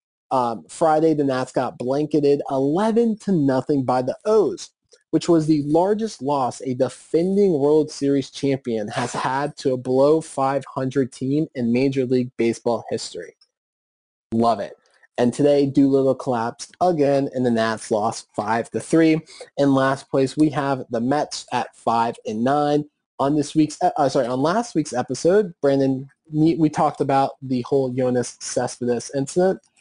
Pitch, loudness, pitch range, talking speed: 140 Hz, -21 LUFS, 130-155 Hz, 155 wpm